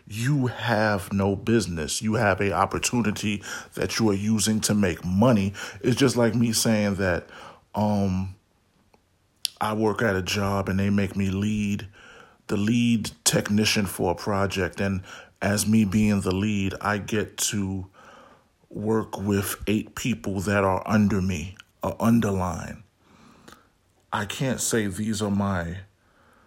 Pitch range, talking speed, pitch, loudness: 95-110 Hz, 145 wpm, 100 Hz, -24 LUFS